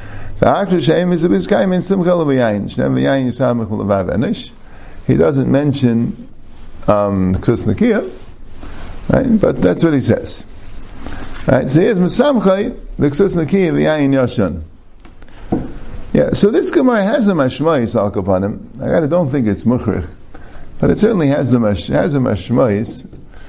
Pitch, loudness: 125 Hz, -15 LUFS